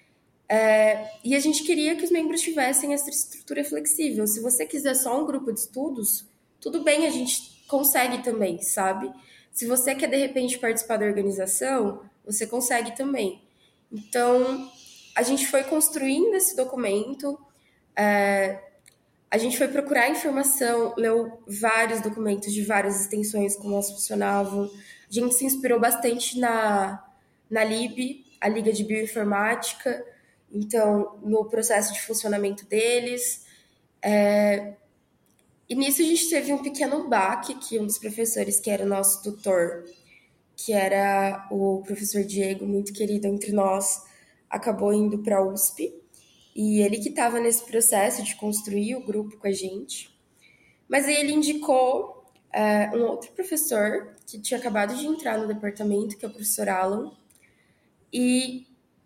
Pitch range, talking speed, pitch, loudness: 205-255 Hz, 145 wpm, 220 Hz, -24 LUFS